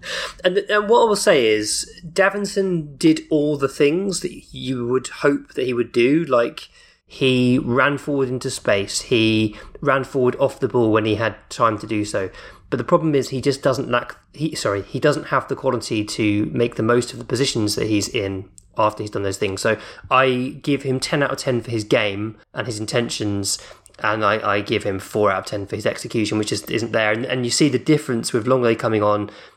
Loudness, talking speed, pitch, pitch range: -20 LUFS, 220 wpm, 125 Hz, 110-140 Hz